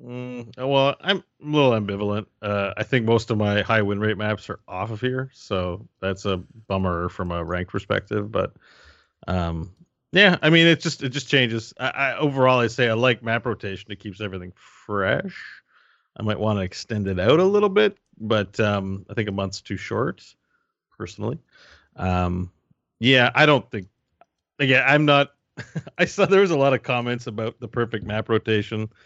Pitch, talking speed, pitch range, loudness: 110 Hz, 190 wpm, 100-135 Hz, -22 LUFS